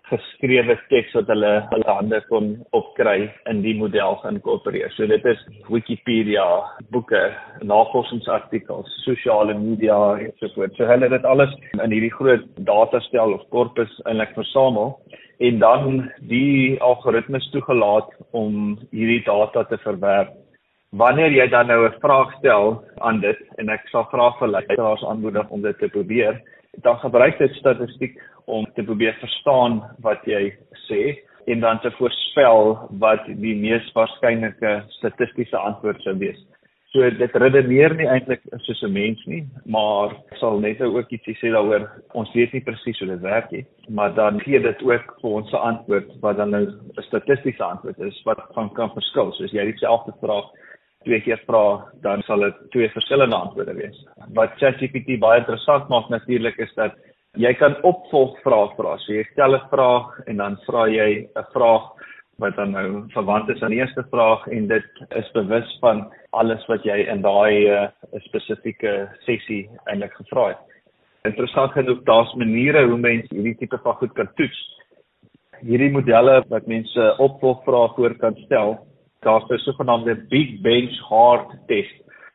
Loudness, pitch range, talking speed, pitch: -19 LUFS, 110-130 Hz, 165 wpm, 115 Hz